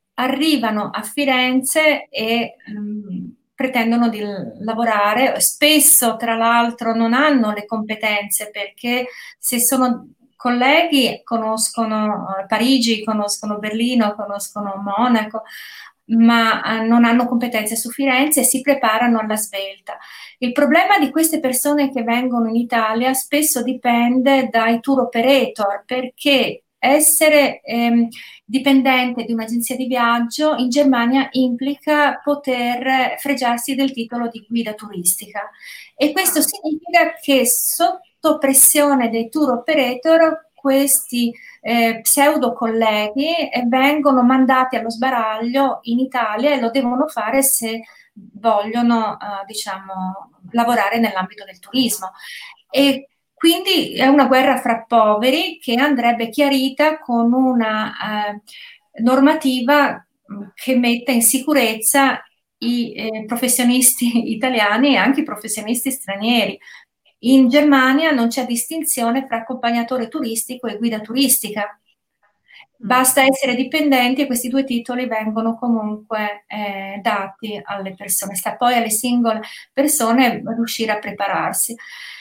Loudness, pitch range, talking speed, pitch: -17 LUFS, 225-270 Hz, 115 wpm, 245 Hz